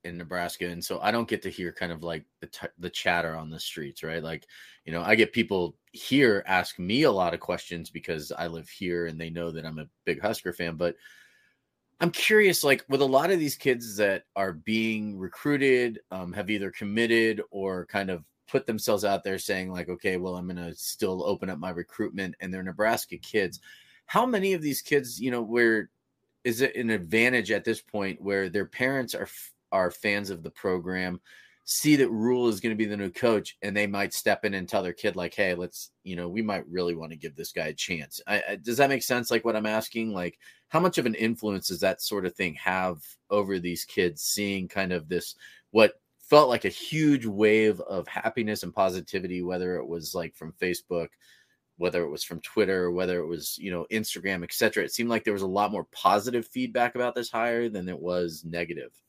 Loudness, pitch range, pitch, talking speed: -27 LUFS, 90-115 Hz, 100 Hz, 225 wpm